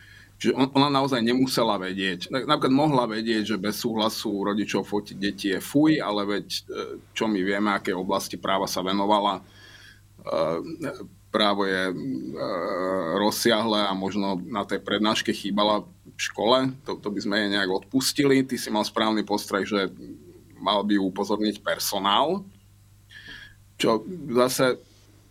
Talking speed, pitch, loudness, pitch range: 135 wpm, 105 Hz, -25 LUFS, 100-115 Hz